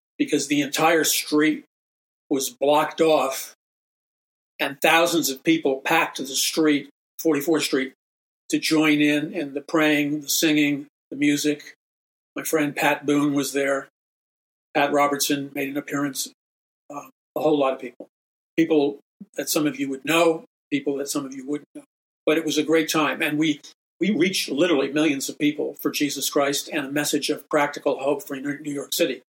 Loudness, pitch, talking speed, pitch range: -22 LUFS, 145 Hz, 175 wpm, 140-155 Hz